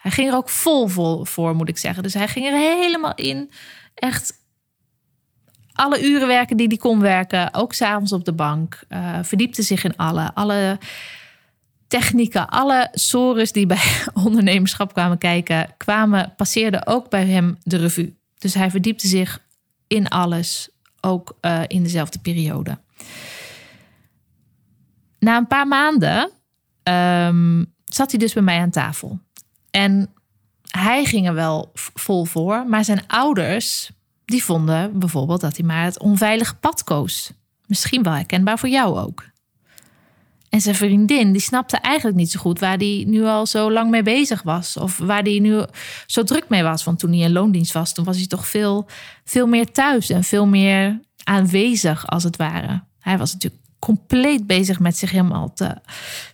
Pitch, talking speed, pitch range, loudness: 195 Hz, 165 wpm, 175-220 Hz, -18 LUFS